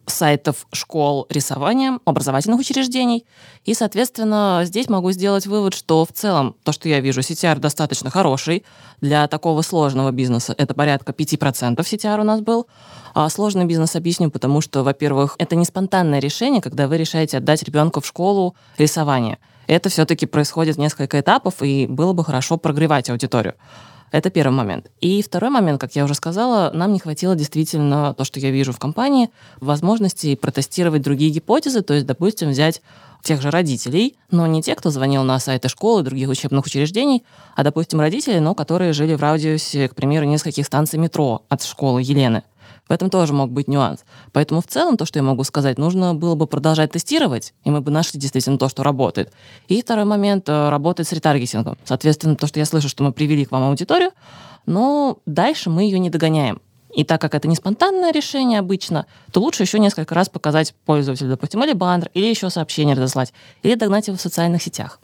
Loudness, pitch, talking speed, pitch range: -18 LUFS, 155 Hz, 185 wpm, 140-185 Hz